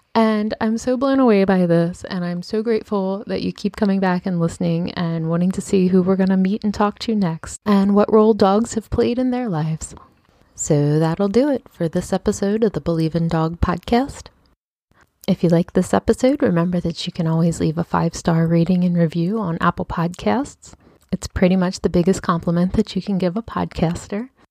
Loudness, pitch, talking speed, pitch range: -19 LUFS, 185 Hz, 210 wpm, 170-215 Hz